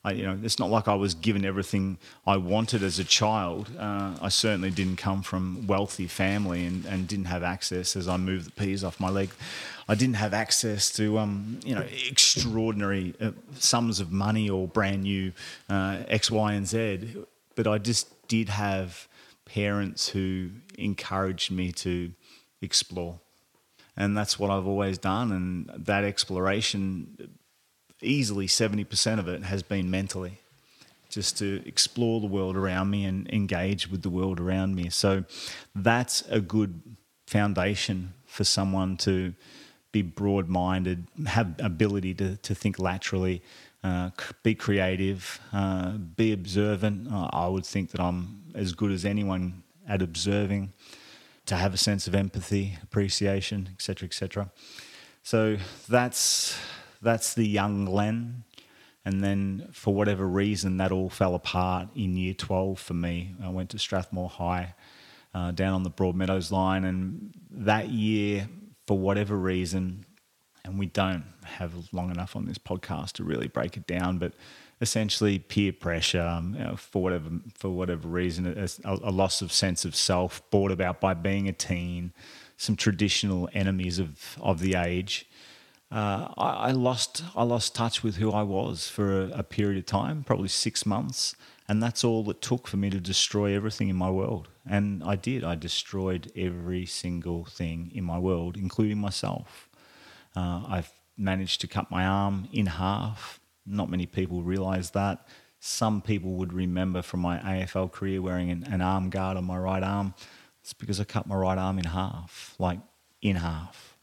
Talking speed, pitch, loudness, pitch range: 165 wpm, 95 Hz, -28 LUFS, 90-105 Hz